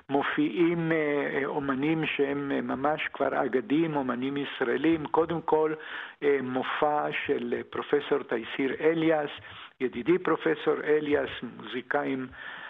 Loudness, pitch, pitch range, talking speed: -28 LUFS, 150 Hz, 135-160 Hz, 90 wpm